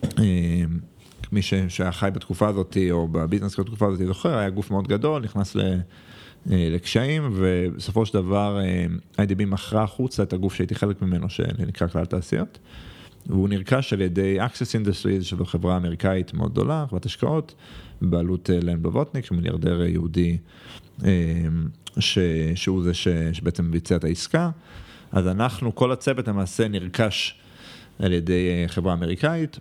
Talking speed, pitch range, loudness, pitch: 140 wpm, 90-105 Hz, -24 LUFS, 95 Hz